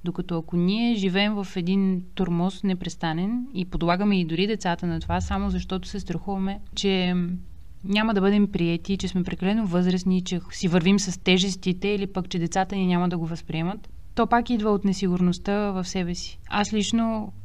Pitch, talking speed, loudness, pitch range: 185 Hz, 180 wpm, -25 LUFS, 180-200 Hz